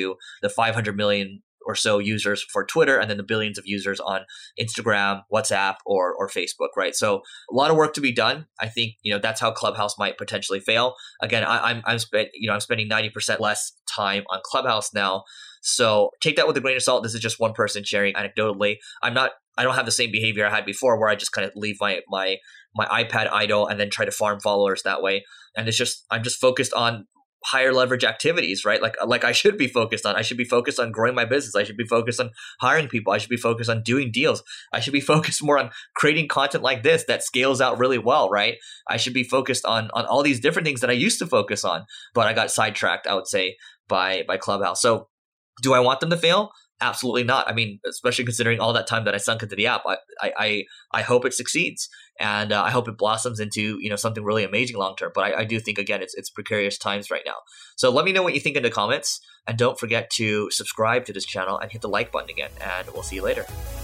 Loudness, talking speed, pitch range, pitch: -22 LUFS, 250 wpm, 105-130 Hz, 115 Hz